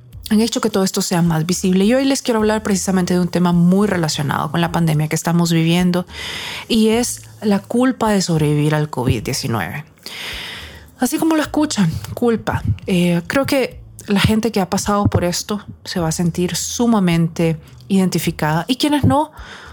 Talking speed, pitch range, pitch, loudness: 175 wpm, 160-220 Hz, 180 Hz, -17 LUFS